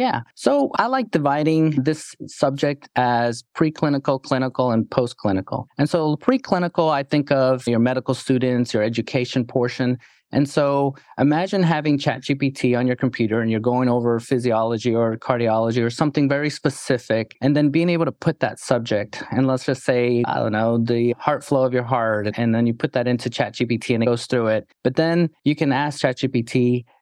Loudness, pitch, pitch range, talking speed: -21 LUFS, 130 Hz, 120-145 Hz, 180 wpm